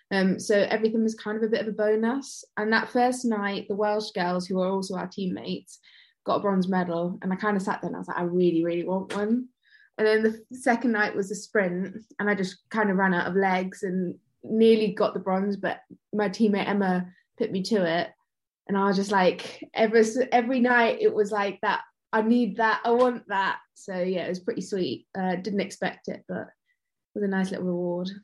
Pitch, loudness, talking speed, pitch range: 205 Hz, -26 LUFS, 225 wpm, 190-225 Hz